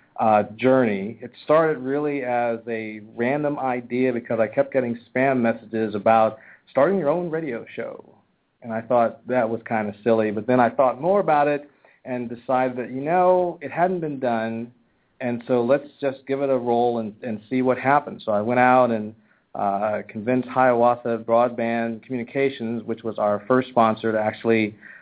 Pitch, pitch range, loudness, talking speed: 120 Hz, 115-130 Hz, -22 LUFS, 180 wpm